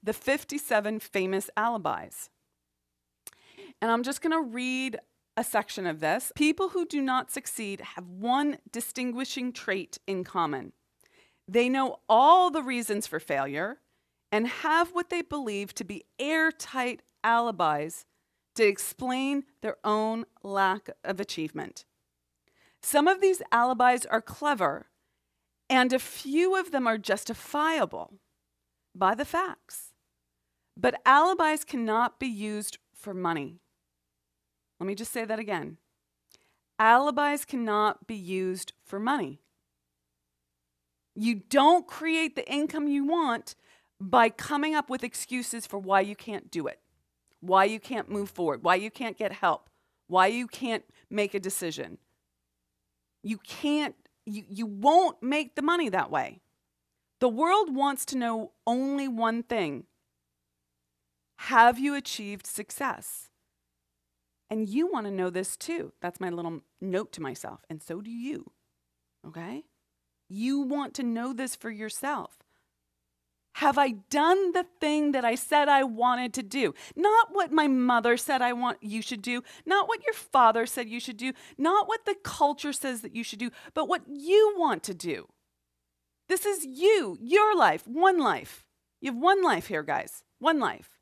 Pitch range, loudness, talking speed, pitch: 190-290 Hz, -27 LUFS, 150 wpm, 235 Hz